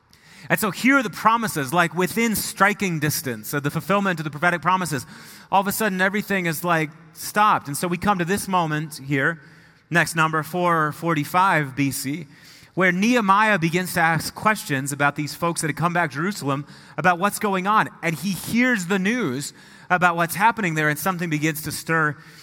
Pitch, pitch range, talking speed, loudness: 170 Hz, 155-195 Hz, 185 wpm, -21 LUFS